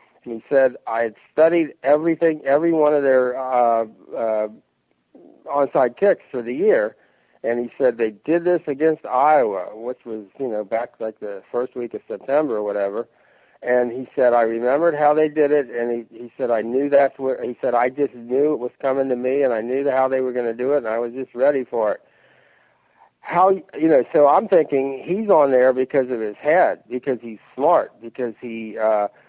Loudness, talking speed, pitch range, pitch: -20 LUFS, 205 wpm, 115-145 Hz, 130 Hz